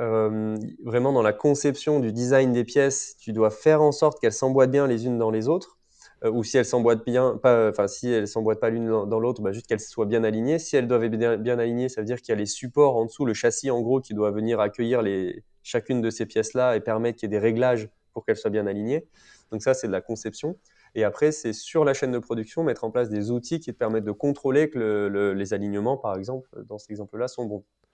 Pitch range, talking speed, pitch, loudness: 110-130 Hz, 260 wpm, 115 Hz, -24 LUFS